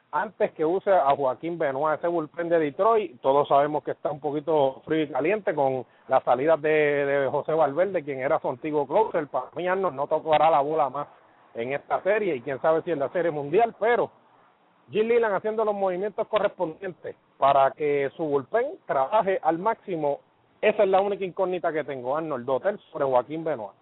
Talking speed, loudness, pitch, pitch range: 190 wpm, -25 LUFS, 155 Hz, 140-190 Hz